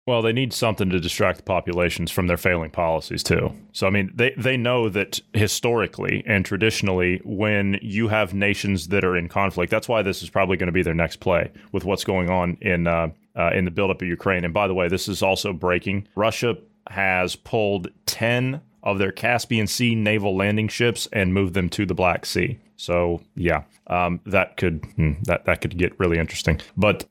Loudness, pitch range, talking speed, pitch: -22 LUFS, 90-110 Hz, 205 wpm, 100 Hz